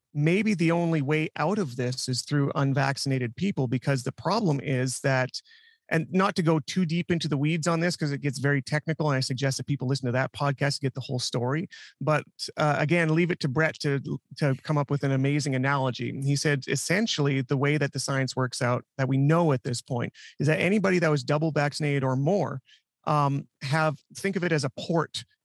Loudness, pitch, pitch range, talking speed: -26 LUFS, 145 Hz, 135-160 Hz, 220 wpm